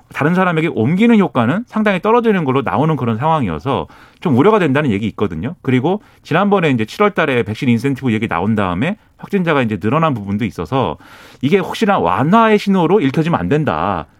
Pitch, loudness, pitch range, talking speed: 135 Hz, -15 LUFS, 110-175 Hz, 430 characters per minute